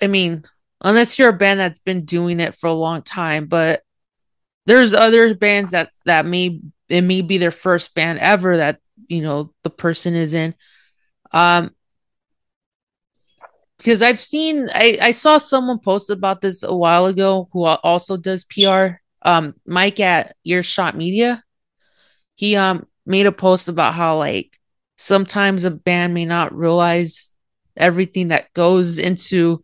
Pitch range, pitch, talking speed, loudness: 170-195 Hz, 180 Hz, 155 wpm, -16 LUFS